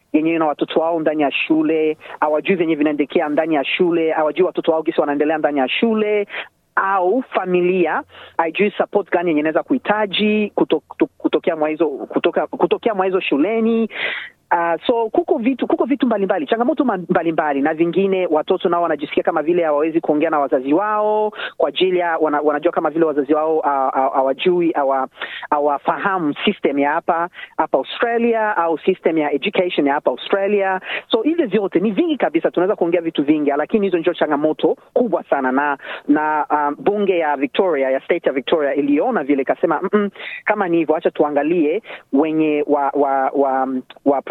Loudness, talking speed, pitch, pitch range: -18 LUFS, 160 wpm, 170 Hz, 150-205 Hz